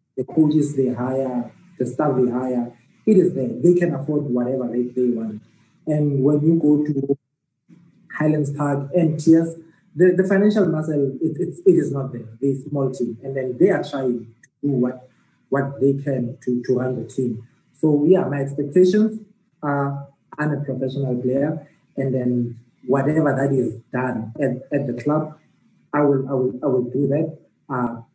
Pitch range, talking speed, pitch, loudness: 125-155 Hz, 180 wpm, 140 Hz, -21 LUFS